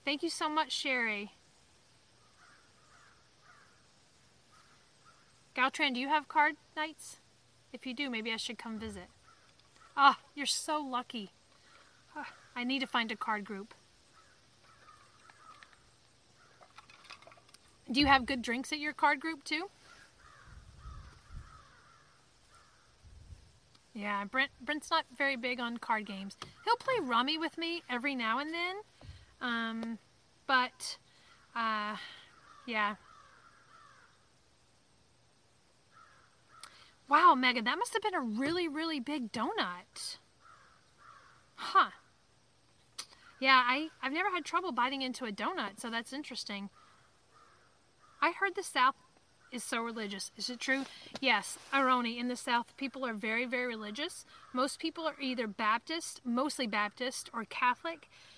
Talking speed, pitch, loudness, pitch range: 120 wpm, 260 Hz, -33 LUFS, 235-310 Hz